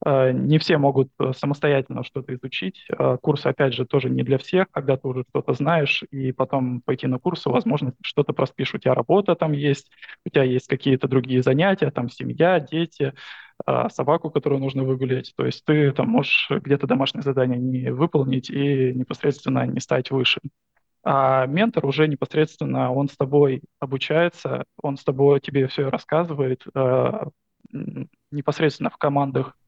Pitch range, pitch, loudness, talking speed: 130-150 Hz, 140 Hz, -22 LUFS, 155 wpm